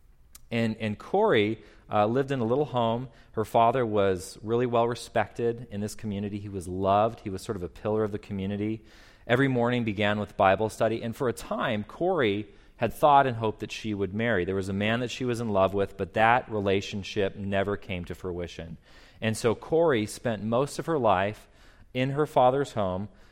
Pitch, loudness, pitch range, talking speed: 105 Hz, -27 LUFS, 100-115 Hz, 200 wpm